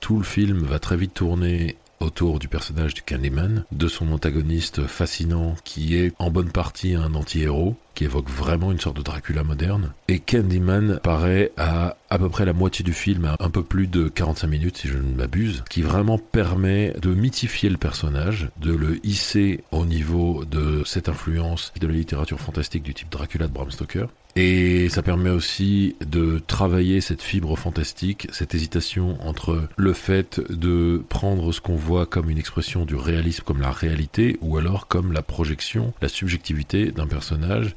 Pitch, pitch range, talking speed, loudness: 85 Hz, 80-95 Hz, 180 wpm, -23 LUFS